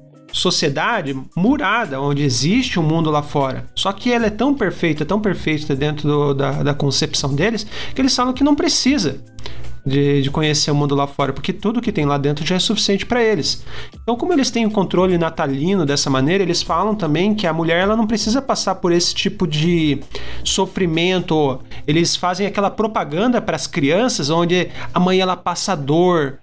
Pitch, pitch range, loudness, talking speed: 170 Hz, 145-200 Hz, -18 LUFS, 195 wpm